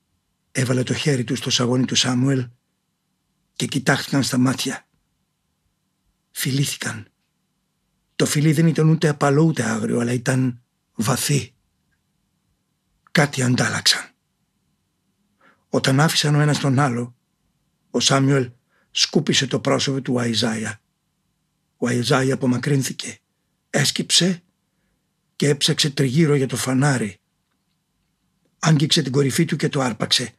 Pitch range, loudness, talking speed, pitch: 125-155 Hz, -20 LUFS, 110 wpm, 135 Hz